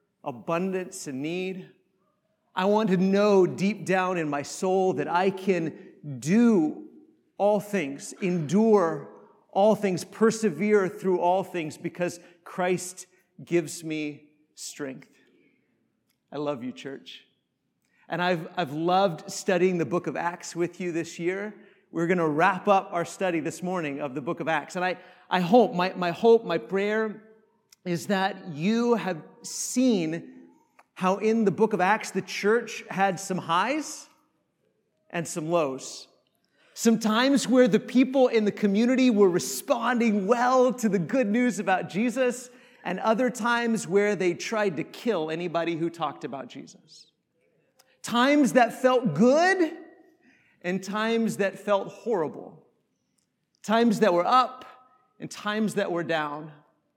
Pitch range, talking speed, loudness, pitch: 175-225 Hz, 145 wpm, -25 LUFS, 195 Hz